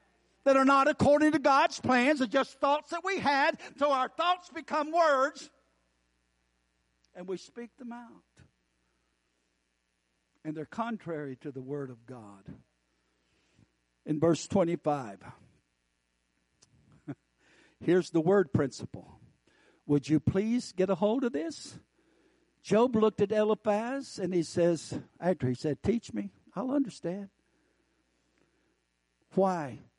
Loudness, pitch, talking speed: -29 LUFS, 170 Hz, 120 wpm